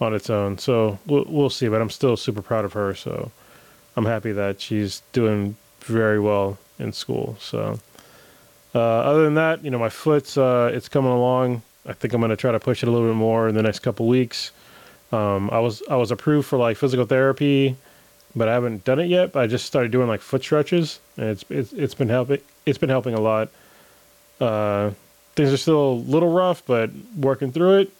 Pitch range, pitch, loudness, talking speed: 110-140 Hz, 125 Hz, -21 LUFS, 215 wpm